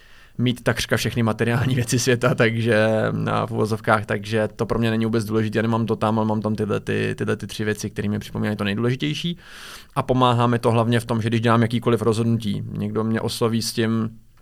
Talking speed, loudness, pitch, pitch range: 210 wpm, -22 LUFS, 115 Hz, 110-120 Hz